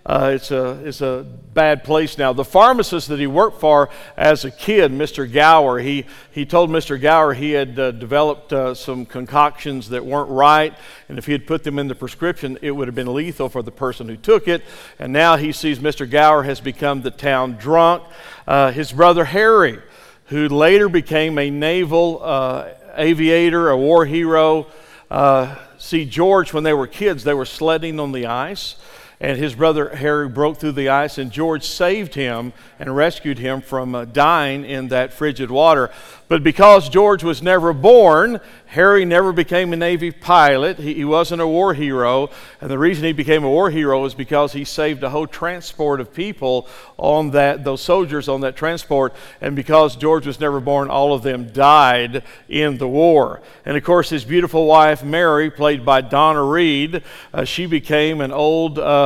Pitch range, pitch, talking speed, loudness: 135-160 Hz, 150 Hz, 190 wpm, -16 LUFS